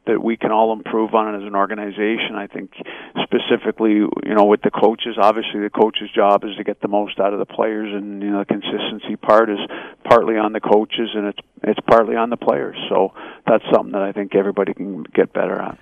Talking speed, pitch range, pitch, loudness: 225 wpm, 100-110 Hz, 105 Hz, -18 LUFS